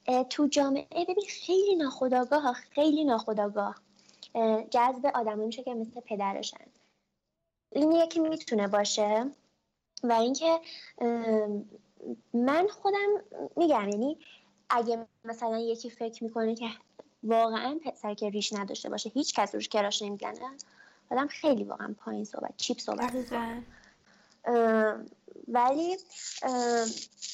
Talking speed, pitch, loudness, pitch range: 110 wpm, 245 Hz, -30 LUFS, 225-290 Hz